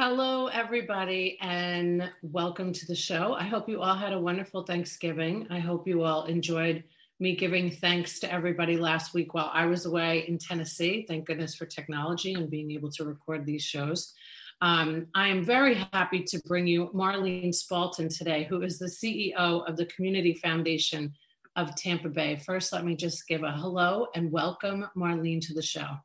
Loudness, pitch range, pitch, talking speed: -29 LUFS, 165-185 Hz, 175 Hz, 180 wpm